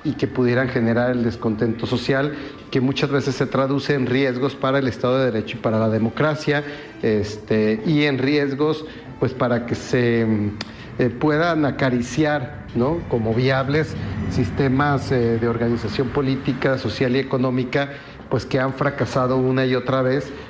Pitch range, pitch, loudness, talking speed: 120-140 Hz, 130 Hz, -21 LUFS, 155 wpm